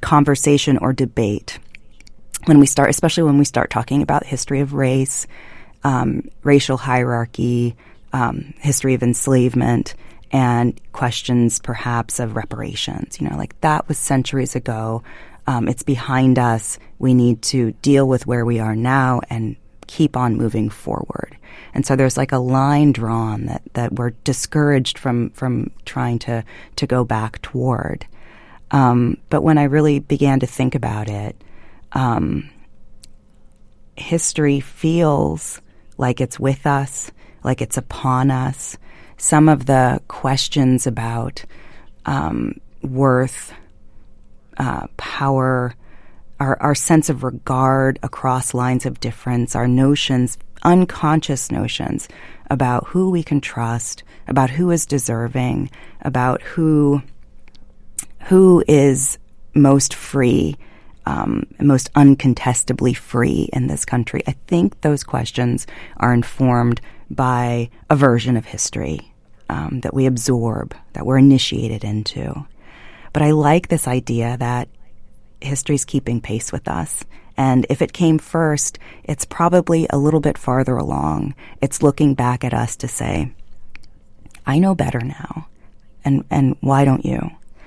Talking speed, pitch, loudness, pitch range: 135 wpm, 130 Hz, -18 LUFS, 120-140 Hz